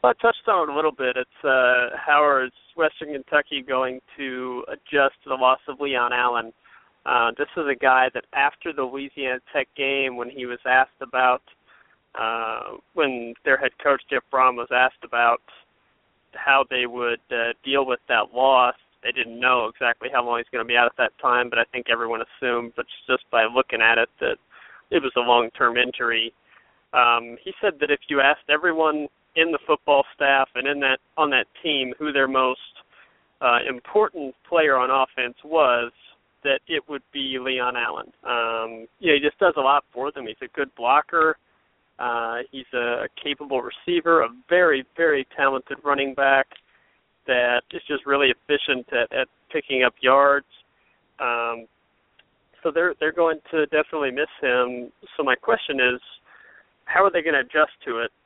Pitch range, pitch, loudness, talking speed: 120-145 Hz, 130 Hz, -22 LUFS, 180 wpm